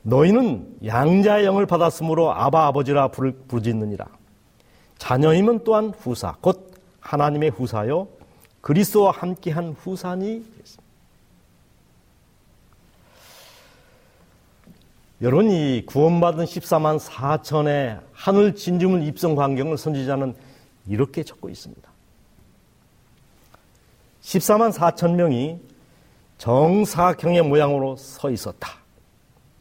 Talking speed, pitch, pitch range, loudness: 215 characters per minute, 155 Hz, 135-180 Hz, -20 LUFS